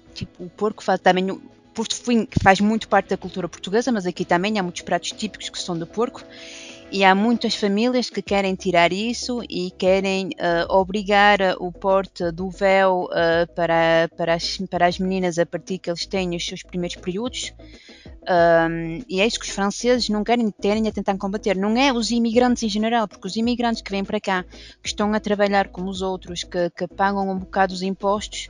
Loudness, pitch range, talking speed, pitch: -21 LUFS, 180-210 Hz, 200 wpm, 195 Hz